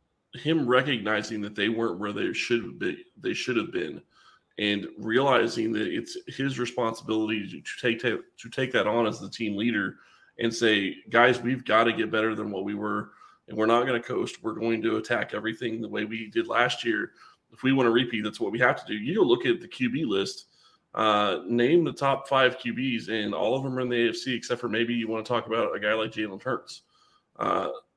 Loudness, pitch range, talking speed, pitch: -27 LUFS, 110-130 Hz, 225 wpm, 115 Hz